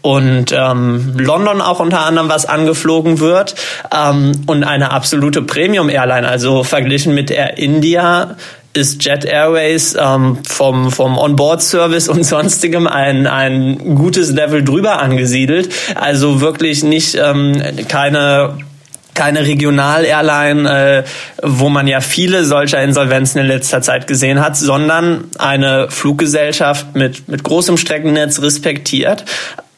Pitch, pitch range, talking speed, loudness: 145 Hz, 135-160 Hz, 130 wpm, -12 LUFS